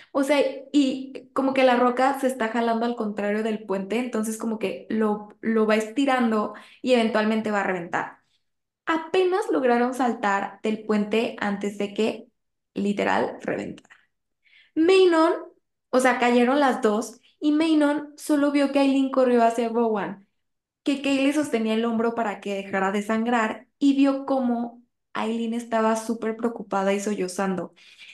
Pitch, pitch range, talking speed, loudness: 235 Hz, 215-270 Hz, 150 wpm, -24 LUFS